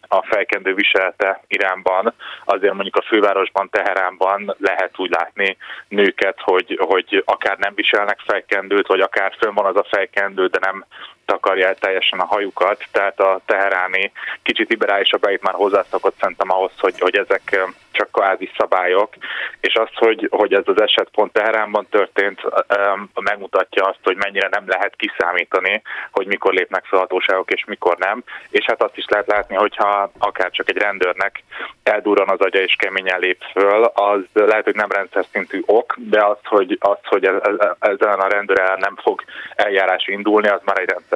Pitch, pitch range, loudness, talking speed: 100 Hz, 95-100 Hz, -17 LUFS, 165 wpm